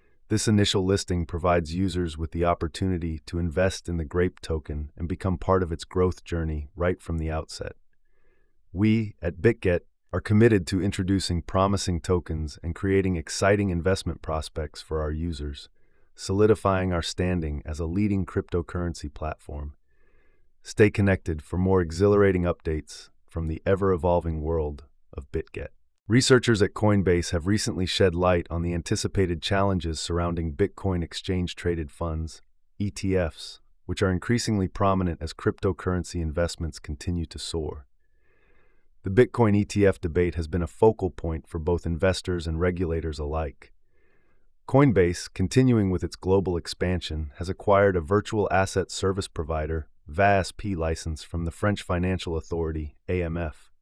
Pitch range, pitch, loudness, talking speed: 80-95 Hz, 90 Hz, -26 LUFS, 140 wpm